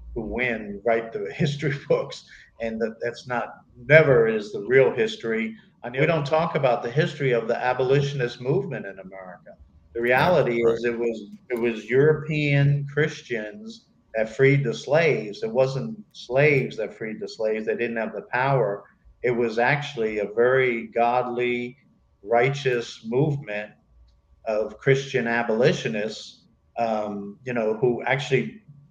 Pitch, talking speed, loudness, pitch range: 125 Hz, 145 wpm, -23 LUFS, 115-145 Hz